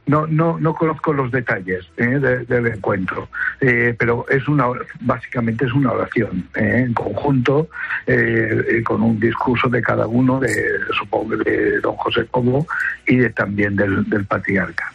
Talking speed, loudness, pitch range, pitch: 165 wpm, -18 LUFS, 115-140 Hz, 125 Hz